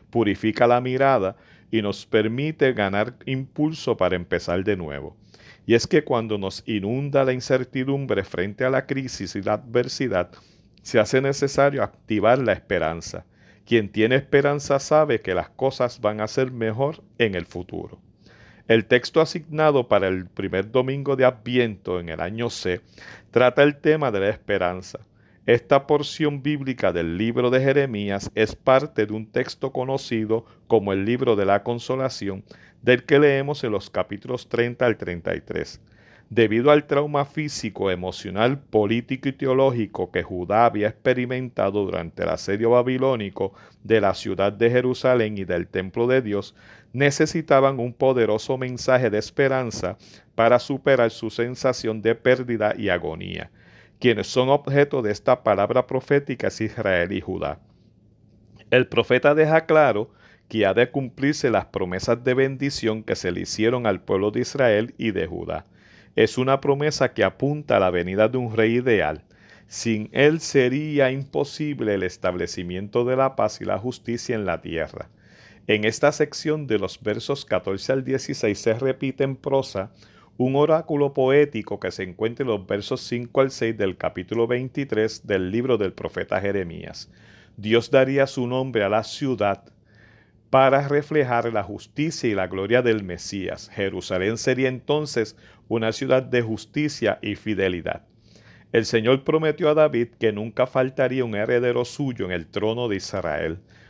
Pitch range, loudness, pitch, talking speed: 105-135 Hz, -22 LUFS, 120 Hz, 155 wpm